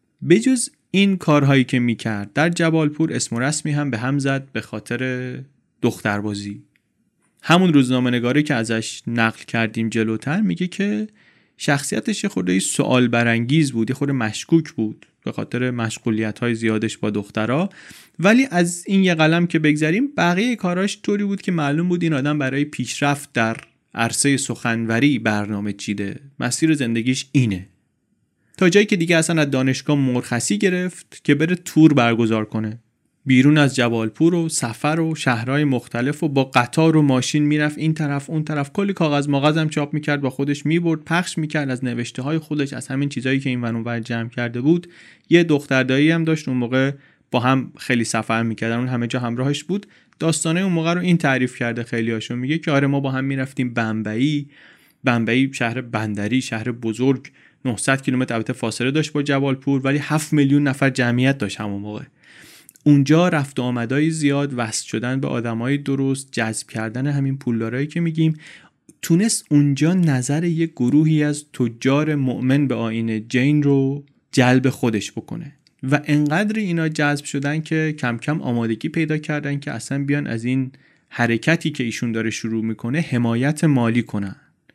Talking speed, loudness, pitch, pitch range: 165 wpm, -20 LUFS, 135 Hz, 120-155 Hz